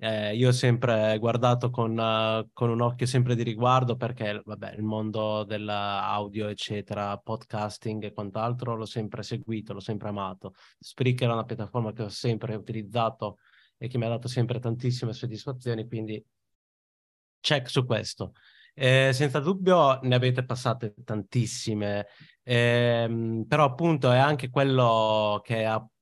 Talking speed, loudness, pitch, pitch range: 145 wpm, -27 LUFS, 115 Hz, 110-125 Hz